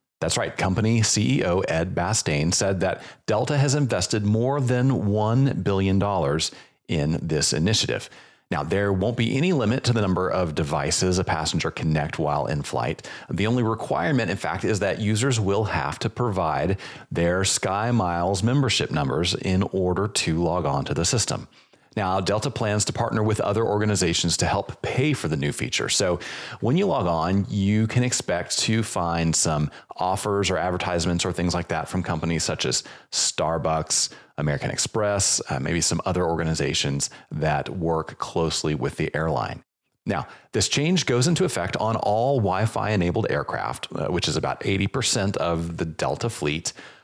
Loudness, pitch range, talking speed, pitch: -23 LUFS, 85-115 Hz, 170 wpm, 100 Hz